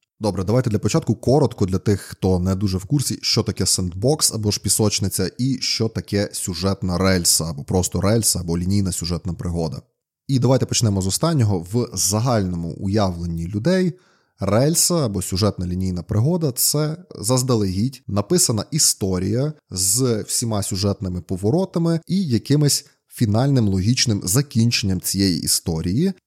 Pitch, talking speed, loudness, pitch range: 105 Hz, 135 wpm, -20 LUFS, 95-130 Hz